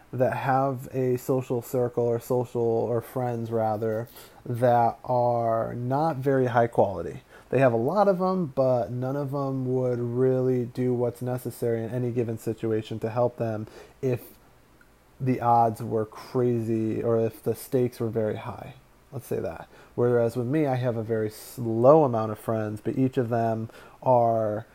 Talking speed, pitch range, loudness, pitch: 165 wpm, 115-130 Hz, -26 LUFS, 120 Hz